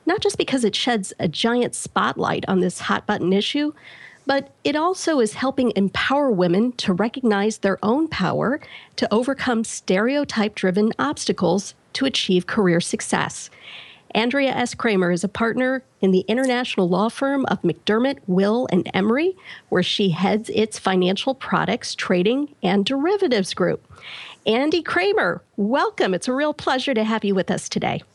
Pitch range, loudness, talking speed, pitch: 195-270 Hz, -21 LUFS, 155 wpm, 225 Hz